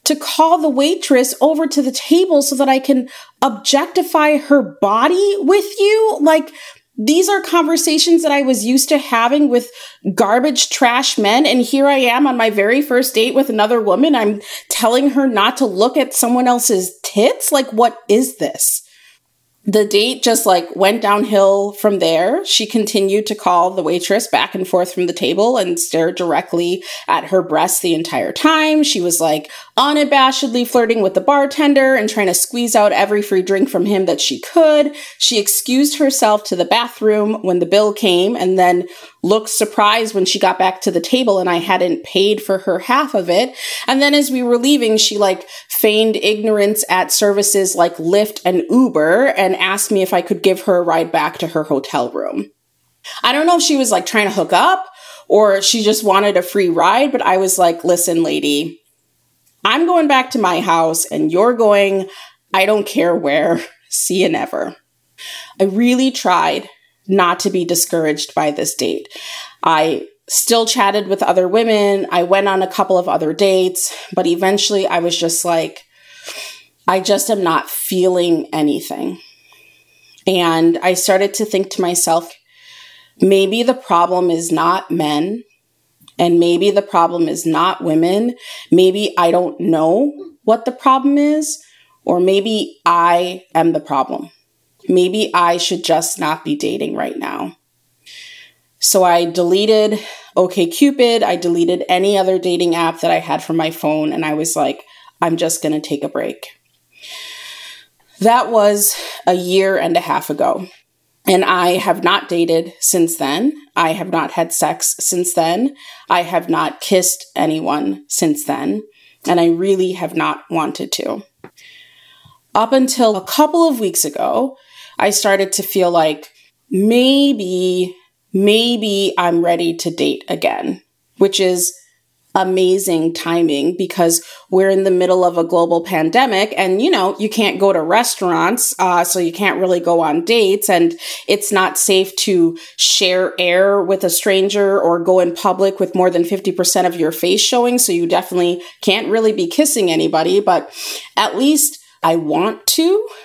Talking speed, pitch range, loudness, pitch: 170 wpm, 180-260 Hz, -14 LUFS, 200 Hz